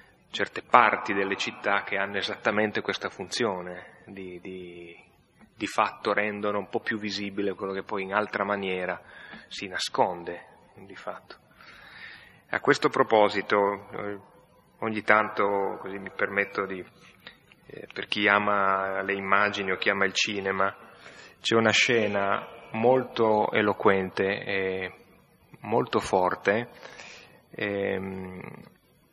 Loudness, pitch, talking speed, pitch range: -26 LUFS, 100 Hz, 115 wpm, 95-105 Hz